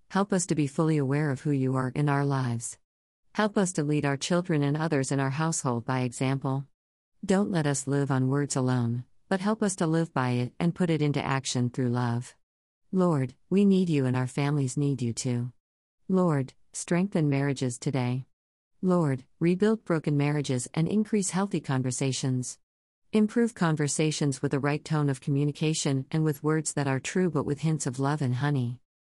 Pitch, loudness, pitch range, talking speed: 145 Hz, -28 LUFS, 130-165 Hz, 185 wpm